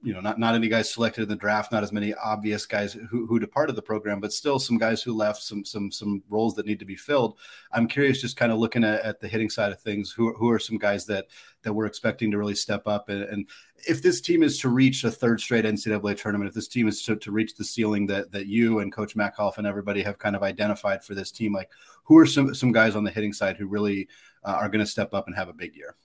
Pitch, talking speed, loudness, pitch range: 105 Hz, 280 wpm, -25 LUFS, 105-115 Hz